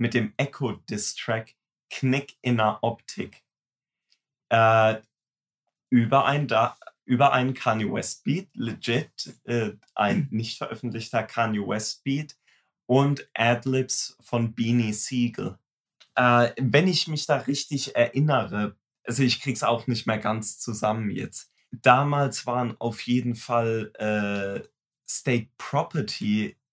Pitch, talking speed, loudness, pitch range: 120 Hz, 125 wpm, -25 LUFS, 110-135 Hz